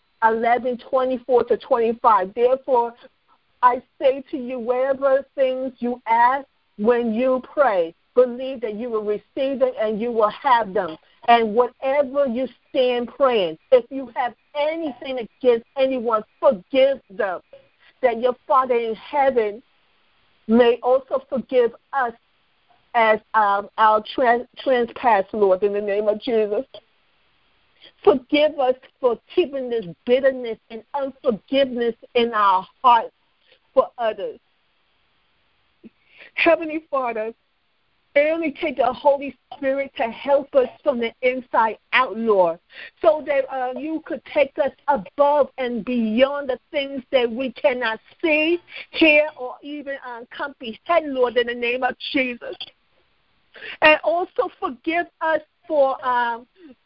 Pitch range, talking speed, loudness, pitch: 235-285 Hz, 125 wpm, -21 LUFS, 255 Hz